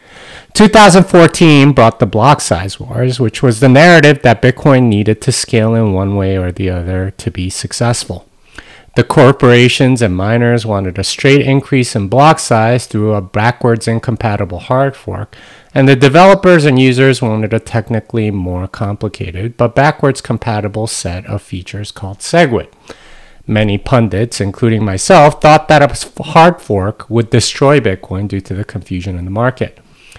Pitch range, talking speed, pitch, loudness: 100-135 Hz, 155 wpm, 115 Hz, -10 LUFS